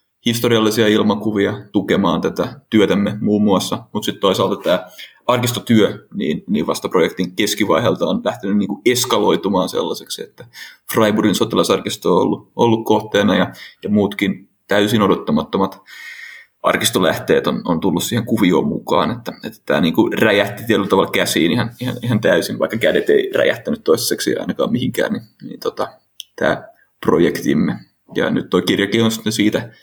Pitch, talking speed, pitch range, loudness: 110 Hz, 145 wpm, 100-120 Hz, -17 LUFS